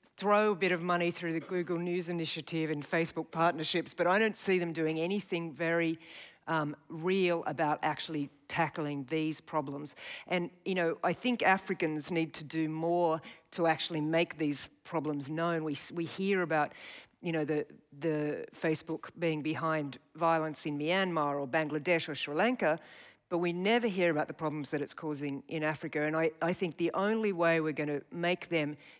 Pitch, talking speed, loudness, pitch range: 165 Hz, 180 wpm, -33 LUFS, 155-175 Hz